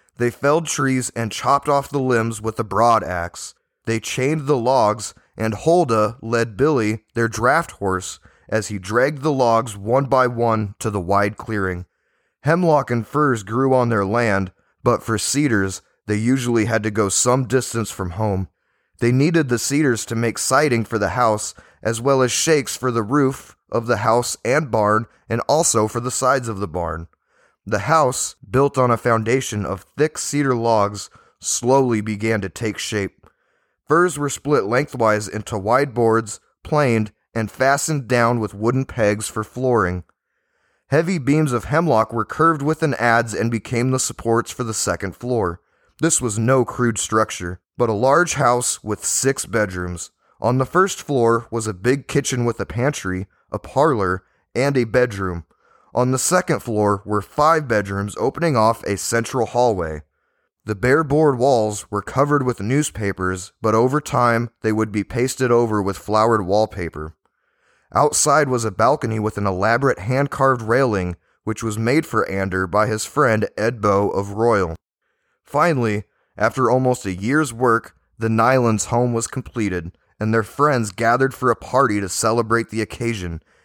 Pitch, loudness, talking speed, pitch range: 115 Hz, -19 LUFS, 165 wpm, 105-130 Hz